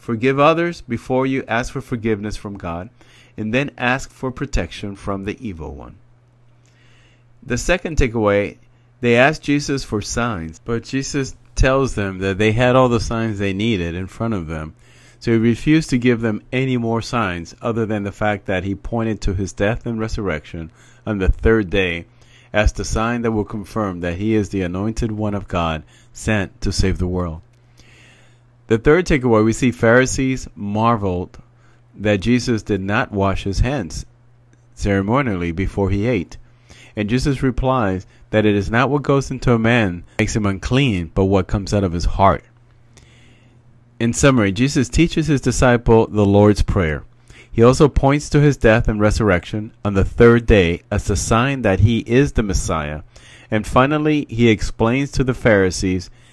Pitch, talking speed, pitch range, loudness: 115 Hz, 175 wpm, 100-125 Hz, -18 LUFS